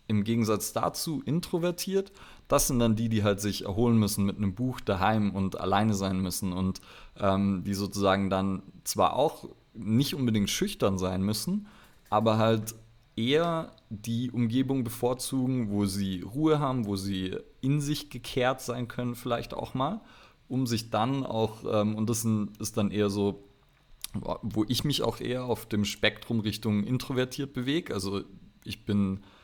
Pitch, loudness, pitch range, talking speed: 110 Hz, -29 LUFS, 100-125 Hz, 160 wpm